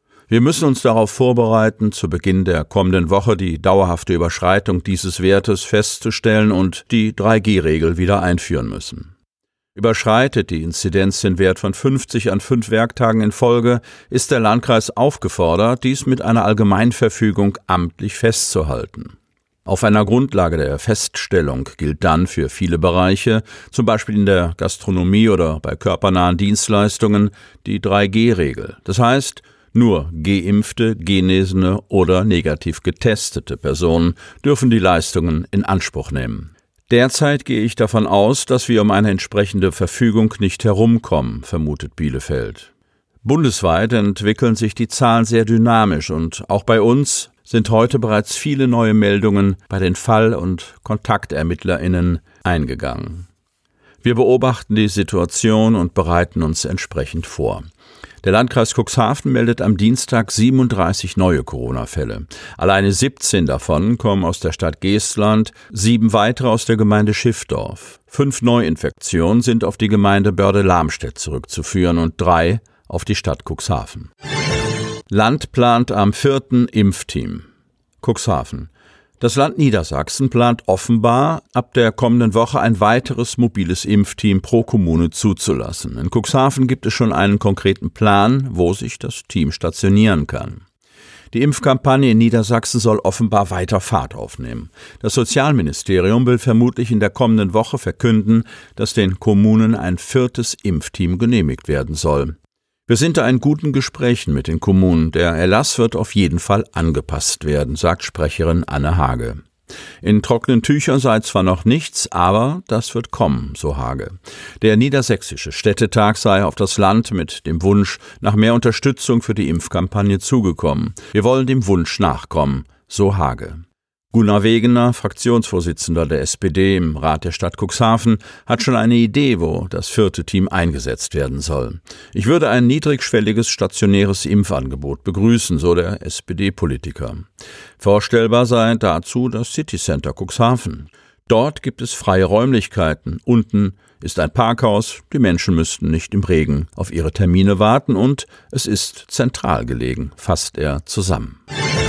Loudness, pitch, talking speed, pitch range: -16 LUFS, 105 Hz, 140 wpm, 90-115 Hz